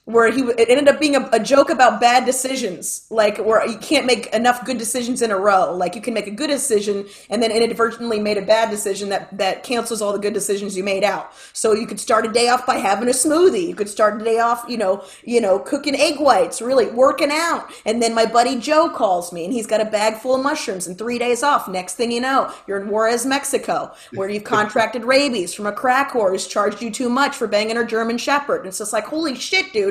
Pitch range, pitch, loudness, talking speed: 210-260 Hz, 230 Hz, -18 LUFS, 255 wpm